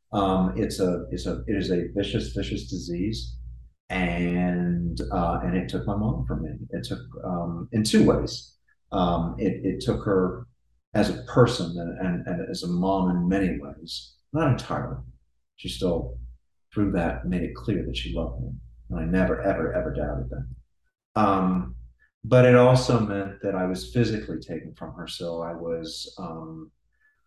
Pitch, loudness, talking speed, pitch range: 90 Hz, -26 LUFS, 175 wpm, 70-100 Hz